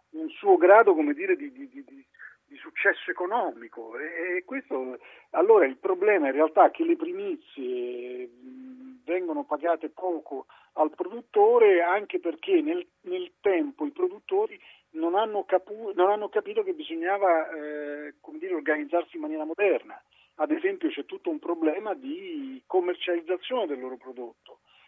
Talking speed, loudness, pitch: 150 wpm, -26 LUFS, 275 Hz